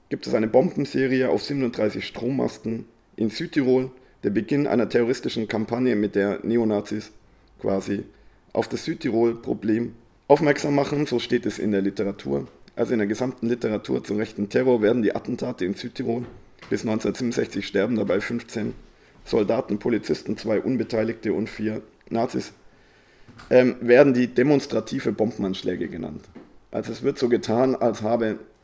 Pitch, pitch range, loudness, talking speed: 115 Hz, 105-125 Hz, -24 LUFS, 140 wpm